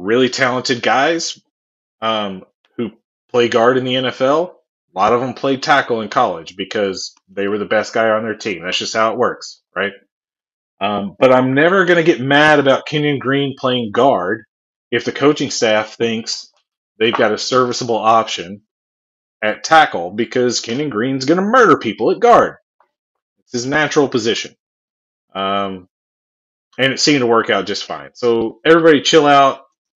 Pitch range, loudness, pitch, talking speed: 110-145 Hz, -15 LUFS, 125 Hz, 170 wpm